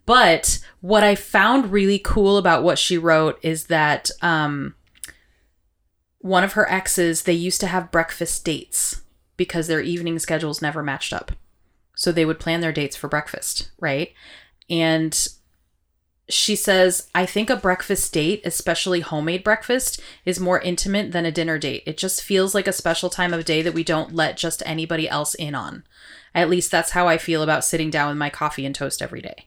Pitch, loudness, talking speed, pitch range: 165 Hz, -20 LUFS, 185 wpm, 155-185 Hz